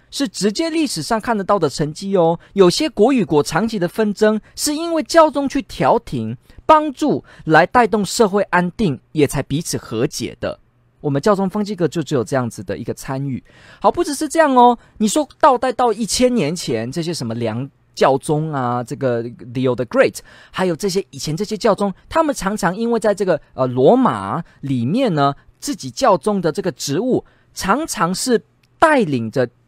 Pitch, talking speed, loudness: 180 Hz, 285 characters per minute, -18 LUFS